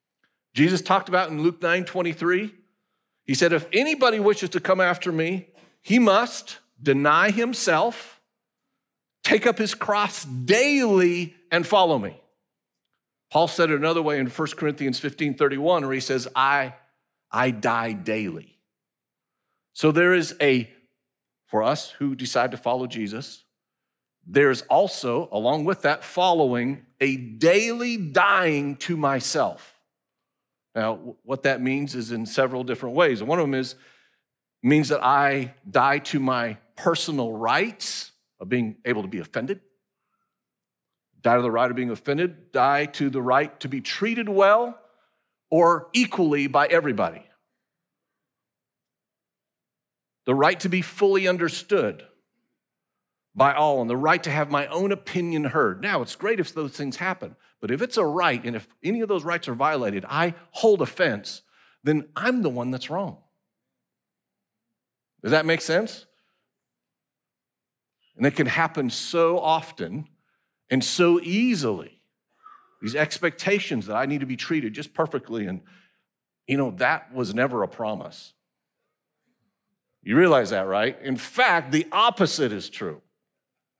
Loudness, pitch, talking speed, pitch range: -23 LUFS, 155 Hz, 145 wpm, 130-180 Hz